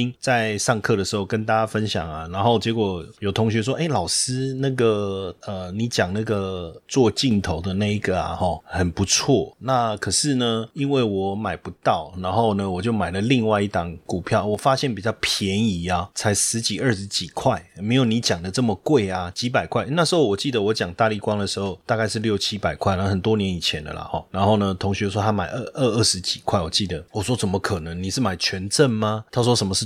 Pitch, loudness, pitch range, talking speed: 105 Hz, -22 LUFS, 95-115 Hz, 315 characters per minute